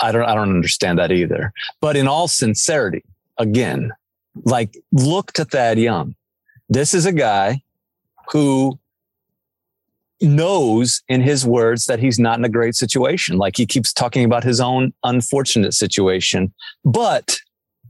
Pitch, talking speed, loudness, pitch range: 120 Hz, 145 wpm, -17 LUFS, 110-135 Hz